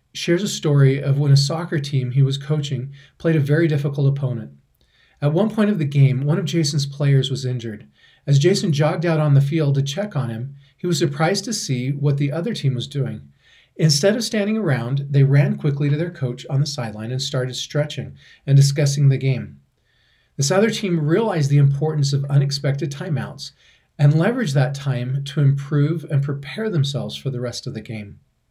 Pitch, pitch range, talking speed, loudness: 145 Hz, 135-160 Hz, 200 wpm, -20 LUFS